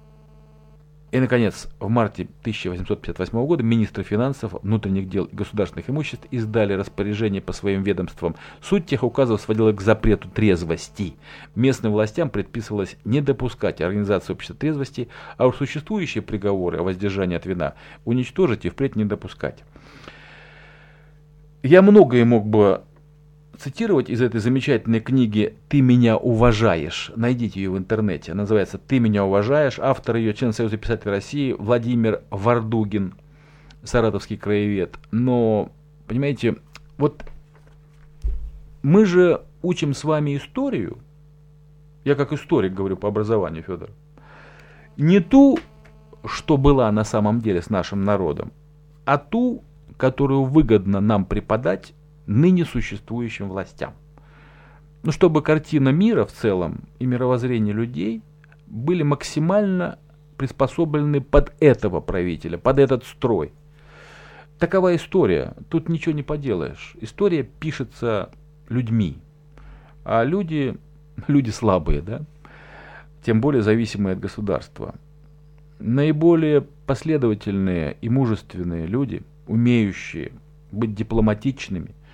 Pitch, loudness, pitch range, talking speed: 125 Hz, -21 LUFS, 105-150 Hz, 115 wpm